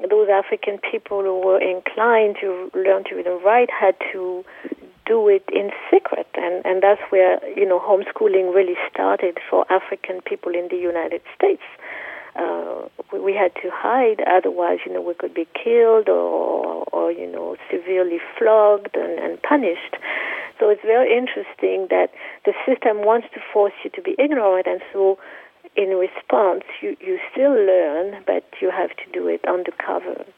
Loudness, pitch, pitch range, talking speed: -20 LUFS, 200 Hz, 185-245 Hz, 170 wpm